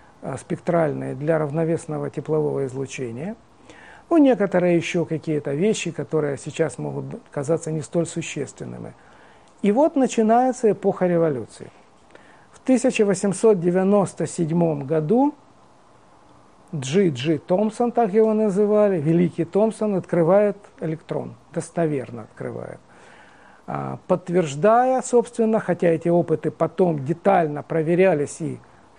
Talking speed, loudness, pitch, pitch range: 95 wpm, -21 LUFS, 170 Hz, 155-205 Hz